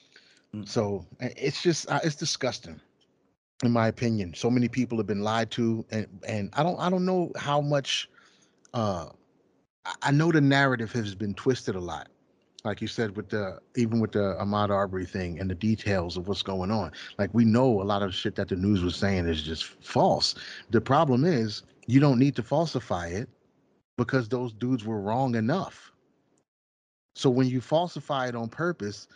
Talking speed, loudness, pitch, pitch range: 185 wpm, -27 LUFS, 115 Hz, 100-130 Hz